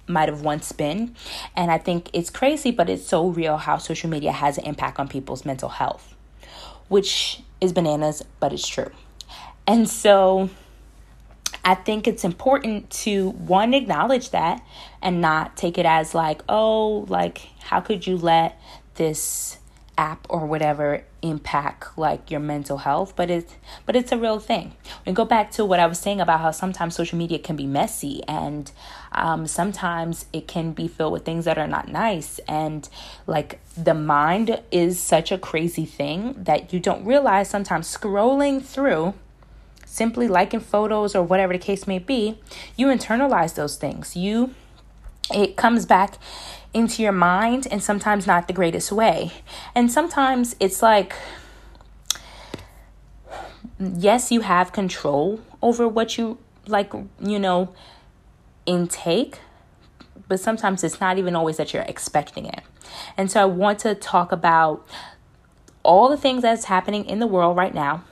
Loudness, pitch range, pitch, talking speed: -22 LUFS, 165-220 Hz, 185 Hz, 160 wpm